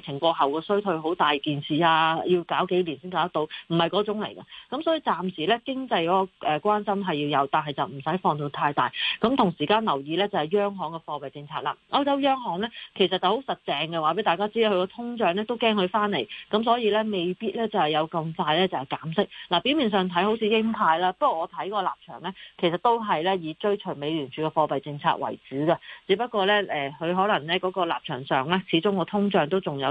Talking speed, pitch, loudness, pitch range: 355 characters per minute, 185 Hz, -25 LUFS, 155-210 Hz